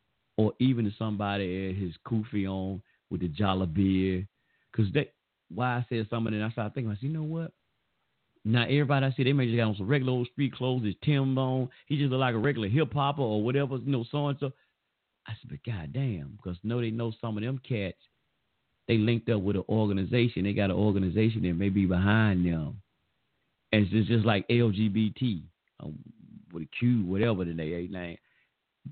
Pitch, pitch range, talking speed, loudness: 110 Hz, 100-130 Hz, 205 wpm, -29 LUFS